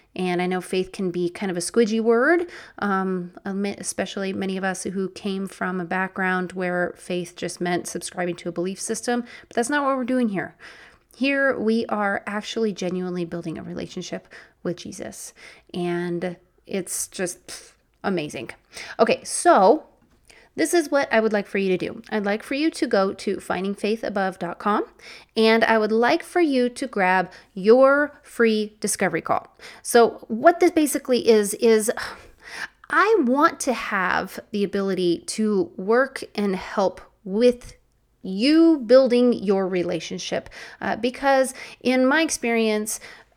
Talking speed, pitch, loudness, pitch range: 150 wpm, 205 Hz, -22 LUFS, 185-245 Hz